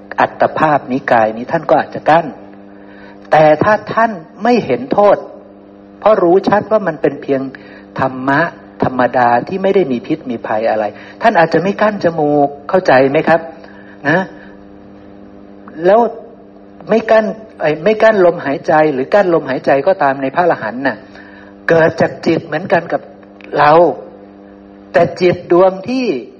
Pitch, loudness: 155 Hz, -13 LUFS